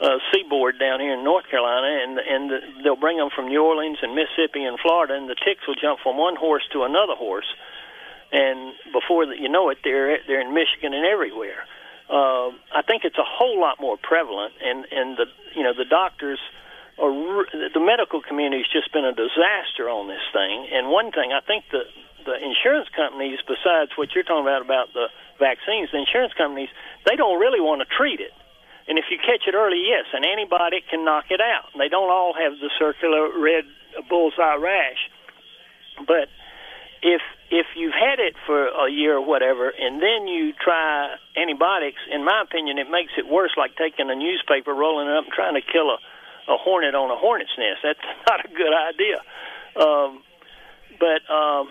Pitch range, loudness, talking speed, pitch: 140-210 Hz, -21 LUFS, 195 wpm, 160 Hz